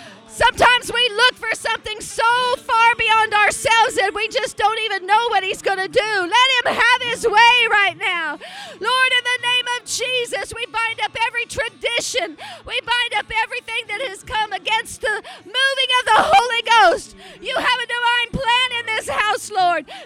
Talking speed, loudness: 185 wpm, -17 LUFS